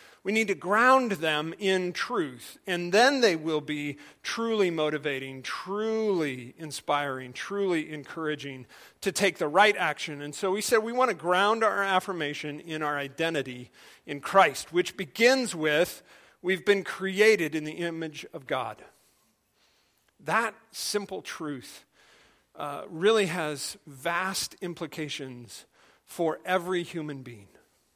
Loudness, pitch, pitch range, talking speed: -27 LUFS, 170 Hz, 150-200 Hz, 130 wpm